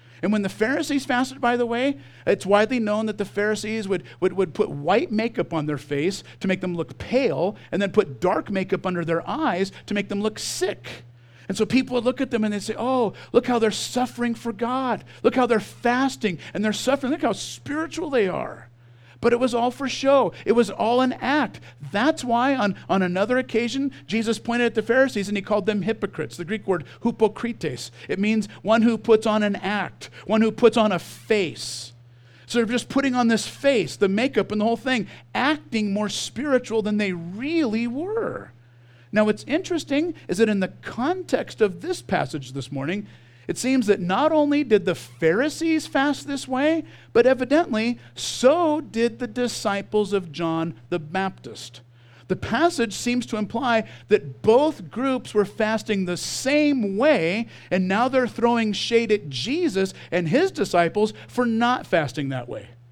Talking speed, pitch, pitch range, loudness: 190 wpm, 220 Hz, 185-250 Hz, -23 LUFS